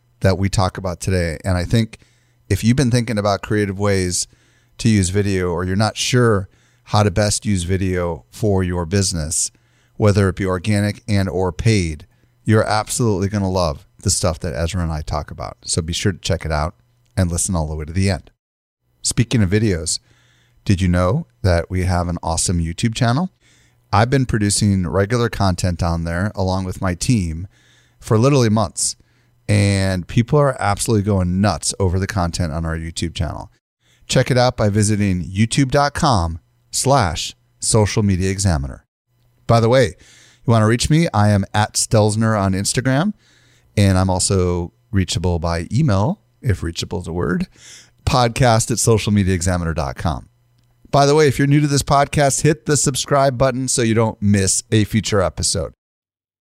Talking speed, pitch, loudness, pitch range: 170 wpm, 105 Hz, -18 LUFS, 90-120 Hz